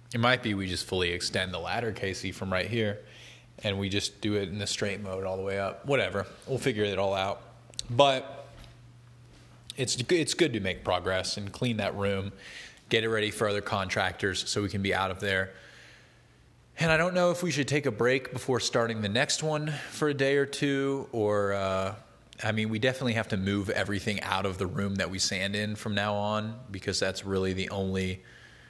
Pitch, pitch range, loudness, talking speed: 105 Hz, 95-125 Hz, -29 LUFS, 215 wpm